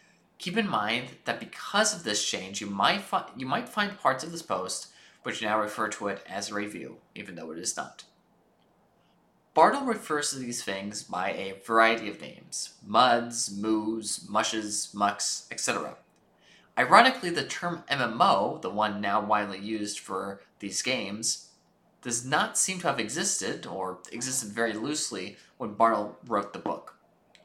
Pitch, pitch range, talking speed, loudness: 110 Hz, 105-130 Hz, 160 wpm, -28 LUFS